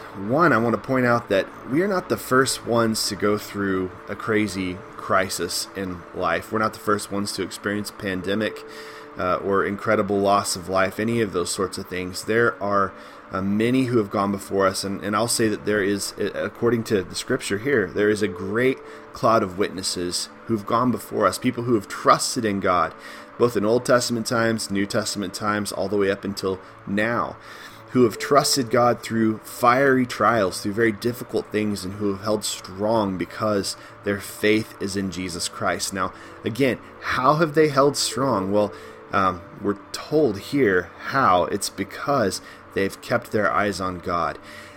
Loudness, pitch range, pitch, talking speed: -23 LUFS, 95-115 Hz, 105 Hz, 185 wpm